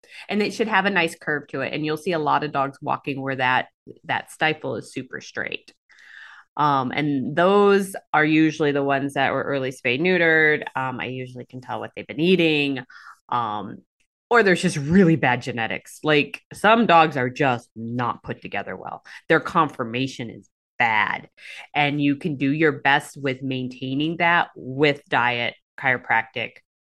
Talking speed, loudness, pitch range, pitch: 170 wpm, -21 LUFS, 130-165 Hz, 145 Hz